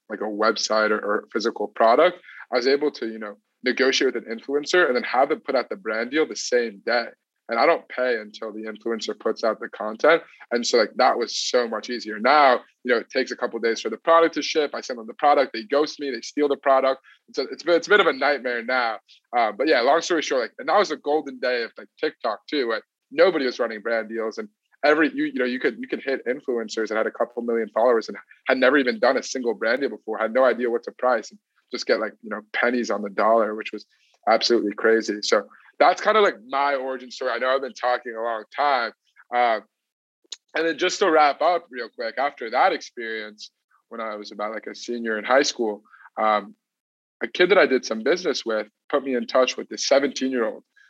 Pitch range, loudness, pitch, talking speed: 110-140 Hz, -22 LUFS, 120 Hz, 245 wpm